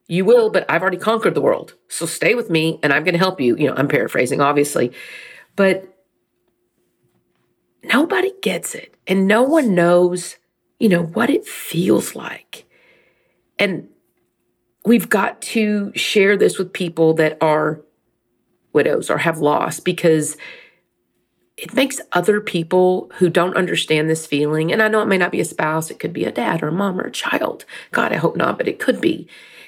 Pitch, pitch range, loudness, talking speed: 180 Hz, 155-215 Hz, -18 LUFS, 180 wpm